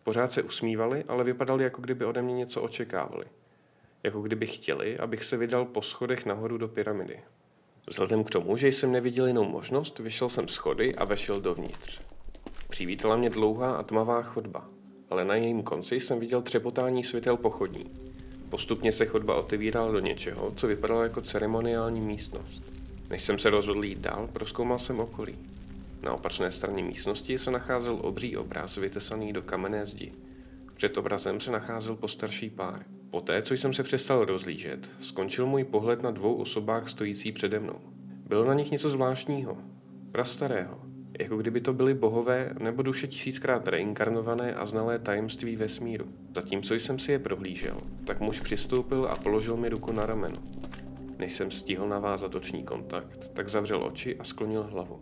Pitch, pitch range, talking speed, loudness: 110 Hz, 95-125 Hz, 165 wpm, -30 LUFS